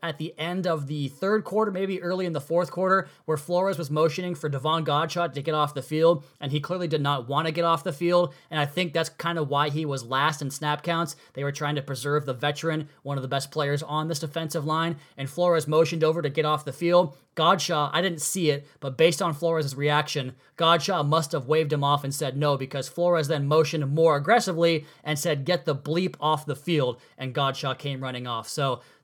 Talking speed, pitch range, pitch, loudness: 235 wpm, 145-170 Hz, 155 Hz, -26 LUFS